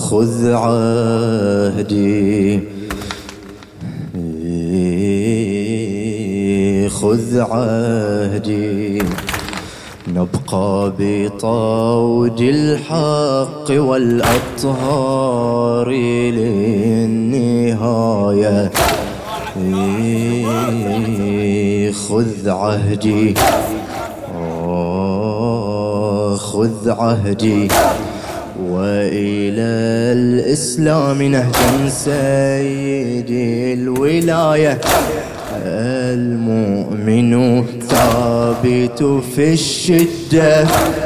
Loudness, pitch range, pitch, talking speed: -16 LUFS, 100-125 Hz, 115 Hz, 30 wpm